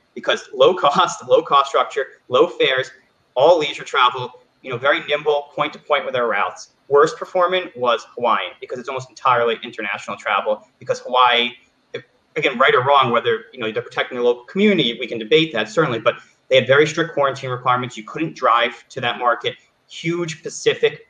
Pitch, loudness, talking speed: 175 Hz, -18 LUFS, 185 wpm